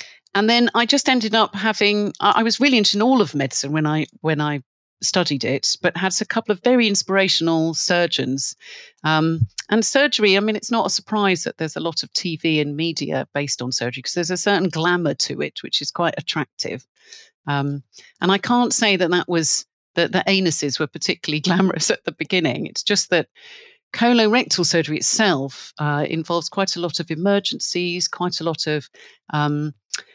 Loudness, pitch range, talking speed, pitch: -19 LUFS, 155-210 Hz, 190 wpm, 175 Hz